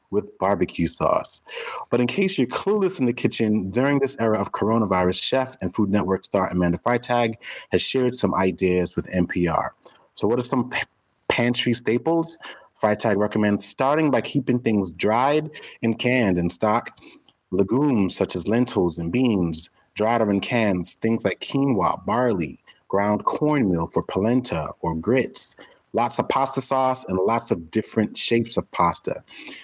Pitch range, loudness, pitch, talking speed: 95-125 Hz, -22 LUFS, 115 Hz, 160 wpm